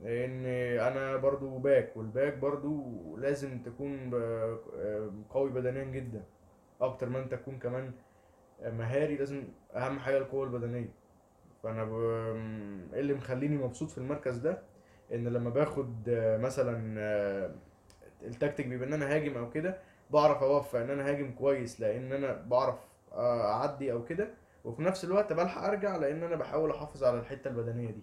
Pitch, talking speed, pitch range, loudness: 130 Hz, 140 wpm, 115-140 Hz, -33 LUFS